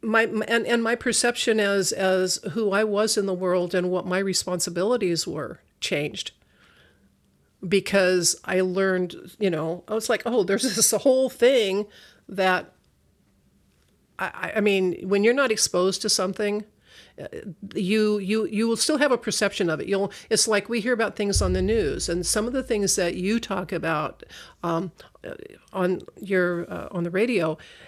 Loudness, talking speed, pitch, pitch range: -23 LUFS, 170 wpm, 200 Hz, 185-225 Hz